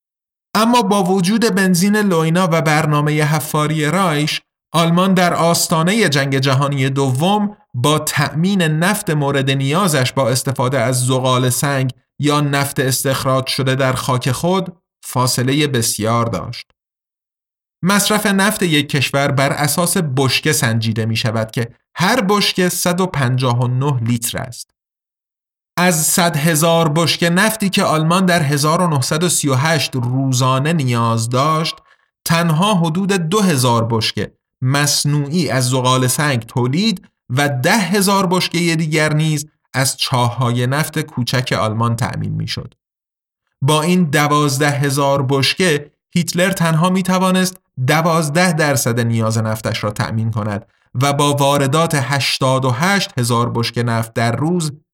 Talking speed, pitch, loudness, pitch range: 120 wpm, 145 Hz, -16 LUFS, 130-175 Hz